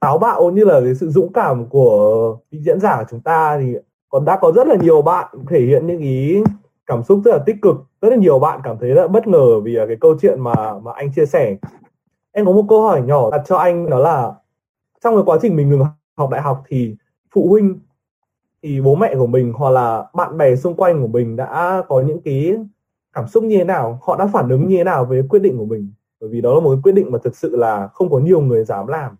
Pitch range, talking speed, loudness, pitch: 130-195 Hz, 260 wpm, -15 LUFS, 155 Hz